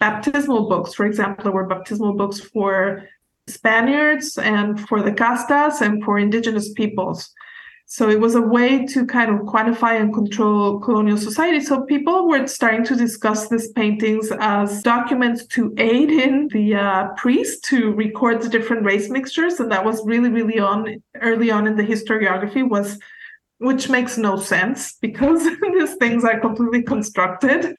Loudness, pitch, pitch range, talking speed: -18 LUFS, 230 Hz, 210-260 Hz, 160 wpm